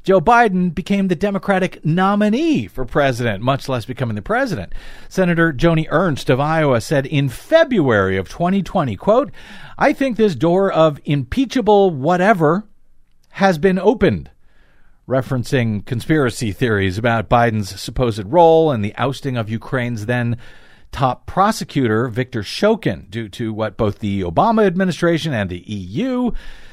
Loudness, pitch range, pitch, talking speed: -17 LUFS, 115-190 Hz, 145 Hz, 135 wpm